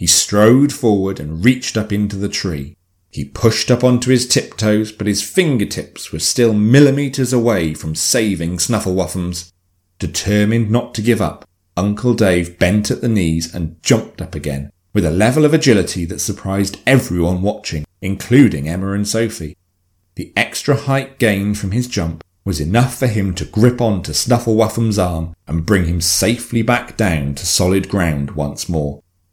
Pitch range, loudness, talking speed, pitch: 90-115 Hz, -16 LUFS, 165 wpm, 100 Hz